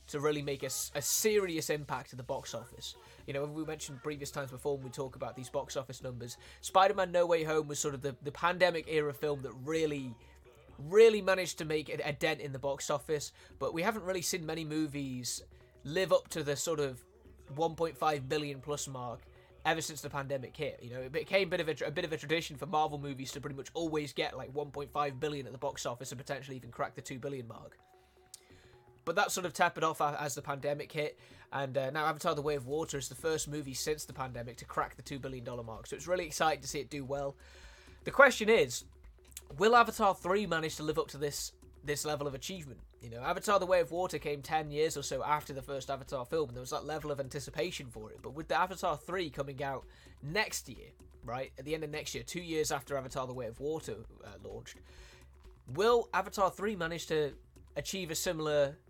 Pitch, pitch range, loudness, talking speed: 145 Hz, 135-160 Hz, -34 LUFS, 230 wpm